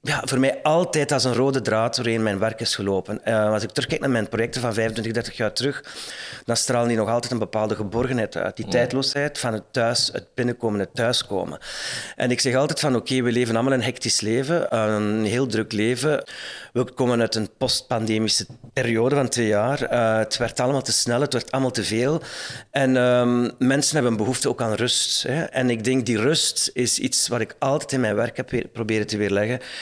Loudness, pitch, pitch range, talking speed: -22 LUFS, 120 Hz, 110-130 Hz, 215 wpm